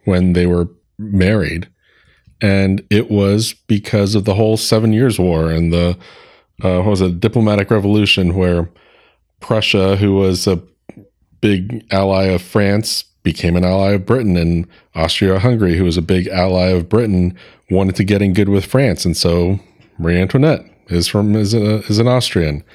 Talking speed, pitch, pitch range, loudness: 165 wpm, 95 Hz, 90-105 Hz, -15 LUFS